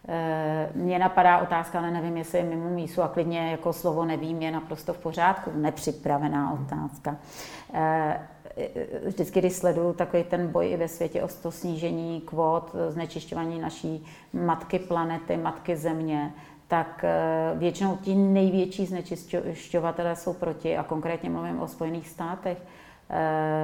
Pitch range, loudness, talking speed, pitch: 160-175 Hz, -28 LUFS, 130 wpm, 165 Hz